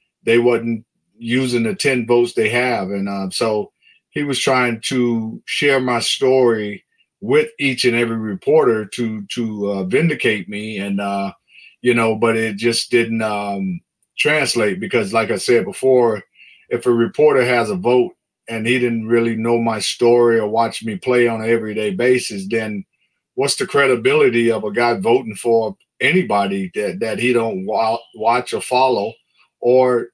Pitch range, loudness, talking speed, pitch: 110-125 Hz, -17 LUFS, 165 wpm, 115 Hz